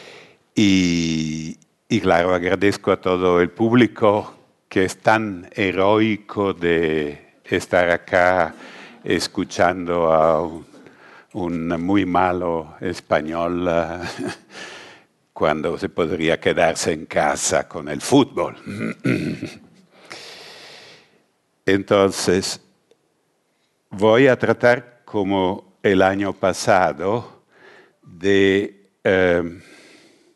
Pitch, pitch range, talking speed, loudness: 95 Hz, 85-105 Hz, 80 wpm, -19 LUFS